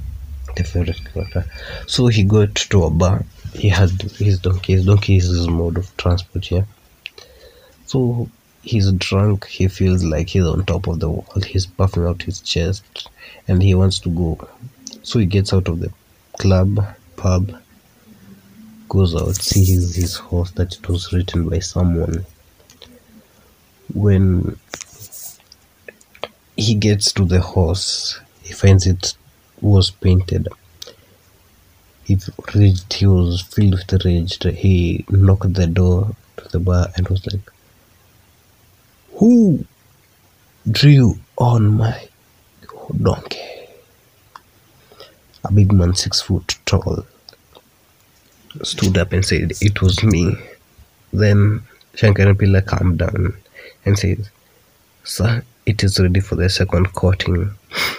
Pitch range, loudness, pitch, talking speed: 90-105 Hz, -17 LUFS, 95 Hz, 125 wpm